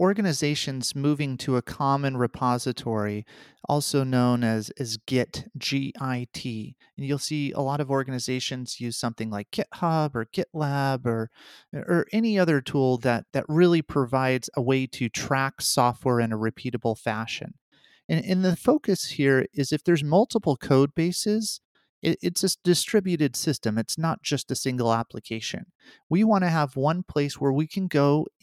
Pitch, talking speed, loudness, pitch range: 140 Hz, 160 wpm, -25 LUFS, 125-160 Hz